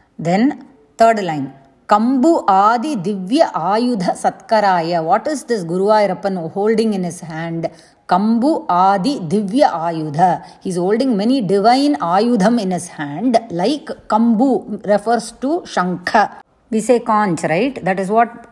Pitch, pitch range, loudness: 210 Hz, 180-235 Hz, -16 LUFS